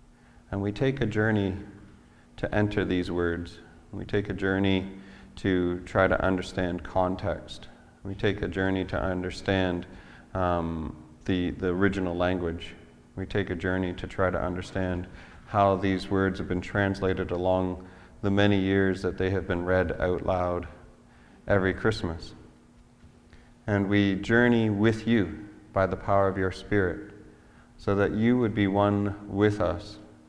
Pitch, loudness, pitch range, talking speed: 95 Hz, -27 LUFS, 90-100 Hz, 150 wpm